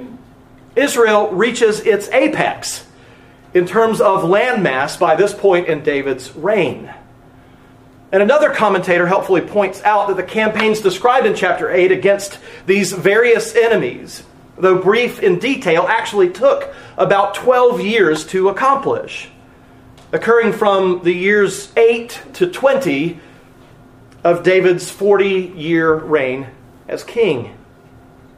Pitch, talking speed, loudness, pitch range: 200 Hz, 120 wpm, -15 LUFS, 175-235 Hz